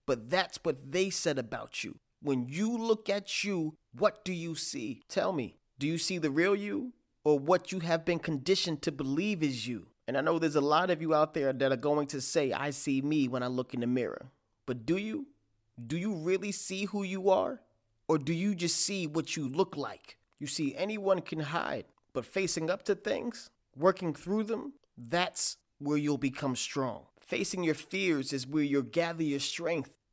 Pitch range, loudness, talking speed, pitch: 140-190 Hz, -32 LUFS, 205 wpm, 165 Hz